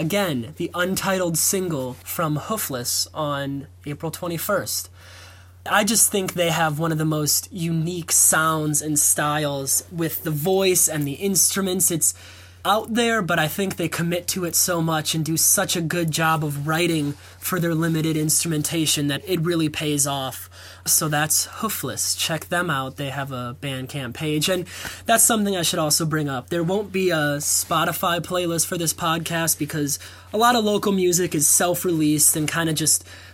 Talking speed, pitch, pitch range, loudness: 175 wpm, 160 Hz, 145-180 Hz, -21 LUFS